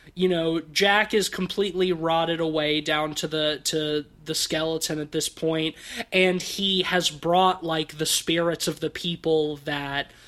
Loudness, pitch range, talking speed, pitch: -24 LUFS, 155-180 Hz, 160 wpm, 160 Hz